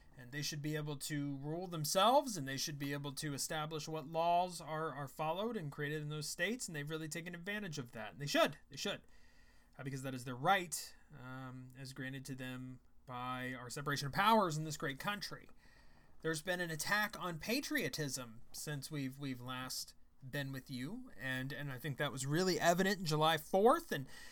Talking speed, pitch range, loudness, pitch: 200 wpm, 135-170 Hz, -38 LUFS, 150 Hz